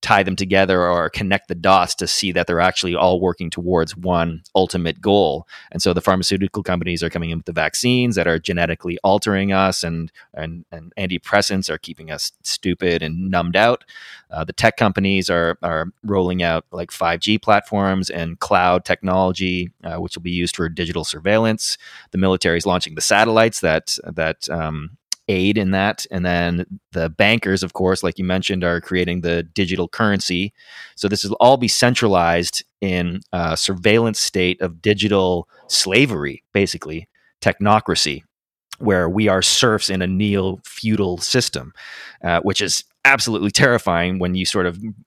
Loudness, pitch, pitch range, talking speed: -18 LUFS, 95 Hz, 85-100 Hz, 170 wpm